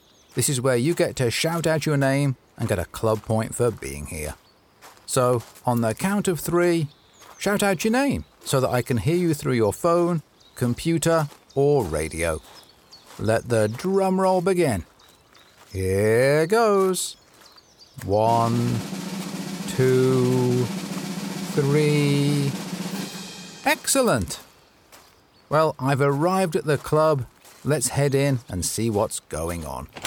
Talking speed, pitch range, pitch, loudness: 130 wpm, 115-185 Hz, 140 Hz, -23 LUFS